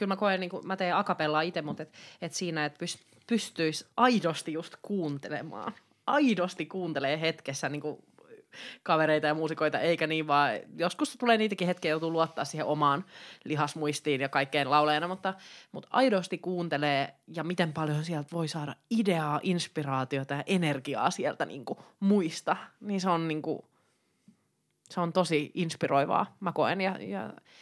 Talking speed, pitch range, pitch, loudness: 160 wpm, 150-185 Hz, 165 Hz, -30 LUFS